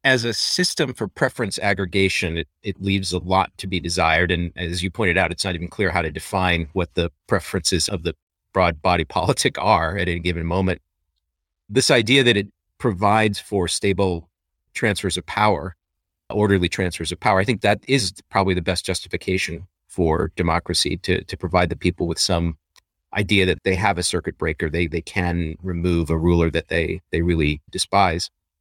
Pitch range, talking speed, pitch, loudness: 85-100 Hz, 185 wpm, 90 Hz, -21 LUFS